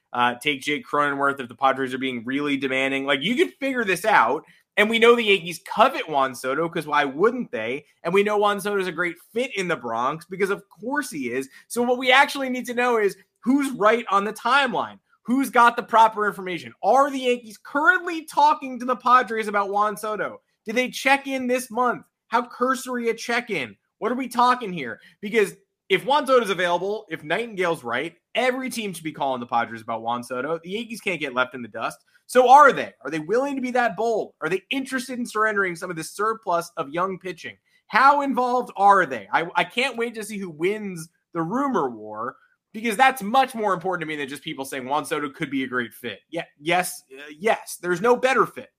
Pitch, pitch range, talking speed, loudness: 205 Hz, 160-245 Hz, 225 wpm, -22 LUFS